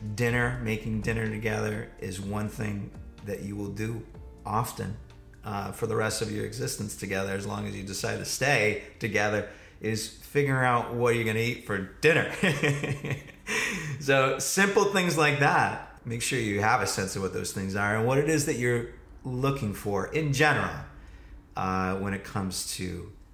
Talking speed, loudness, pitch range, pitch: 175 wpm, -28 LUFS, 100-130 Hz, 110 Hz